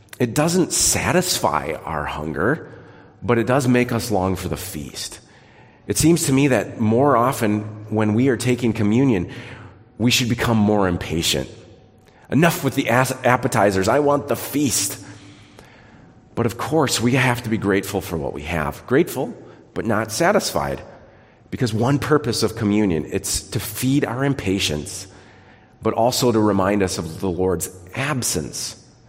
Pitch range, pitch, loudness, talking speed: 95-125 Hz, 110 Hz, -20 LUFS, 155 wpm